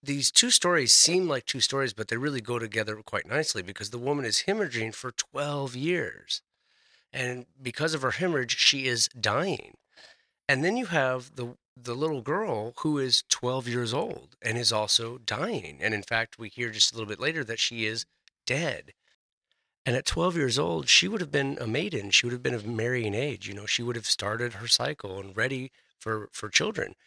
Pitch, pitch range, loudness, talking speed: 120 Hz, 115-140 Hz, -26 LUFS, 205 wpm